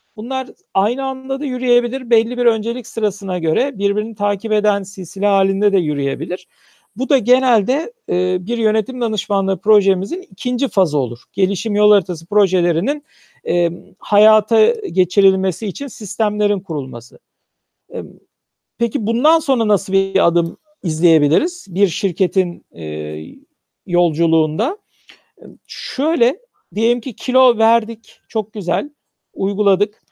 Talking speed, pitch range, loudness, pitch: 110 wpm, 185-240 Hz, -17 LUFS, 205 Hz